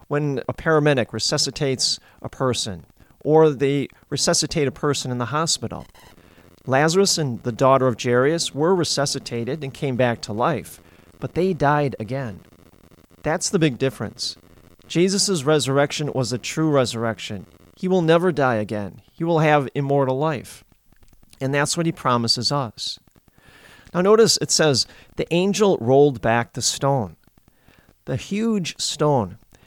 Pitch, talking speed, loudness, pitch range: 135 Hz, 140 wpm, -21 LUFS, 115-155 Hz